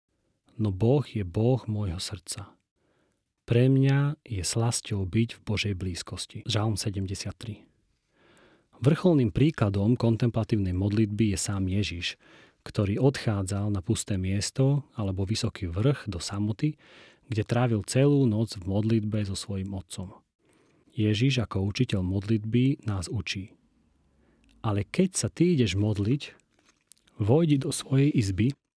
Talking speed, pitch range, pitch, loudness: 120 wpm, 100-125 Hz, 110 Hz, -27 LUFS